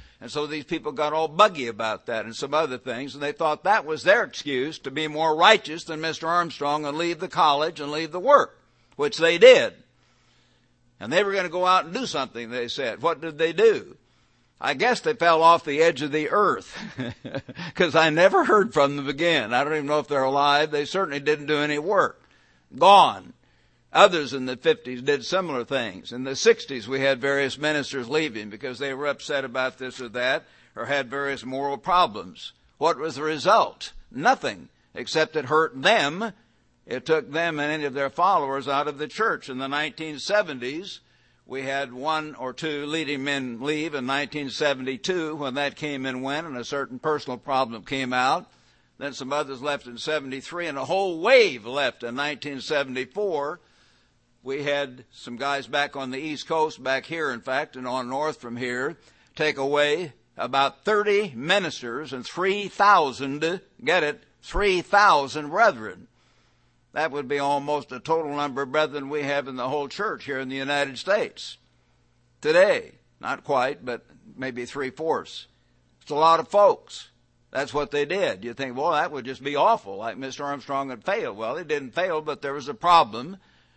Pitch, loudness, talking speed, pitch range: 145 Hz, -24 LUFS, 185 wpm, 130-160 Hz